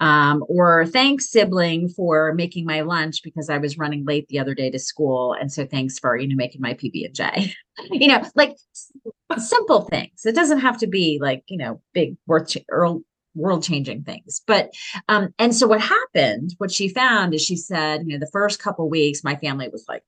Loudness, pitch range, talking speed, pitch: -20 LUFS, 150-205 Hz, 195 wpm, 165 Hz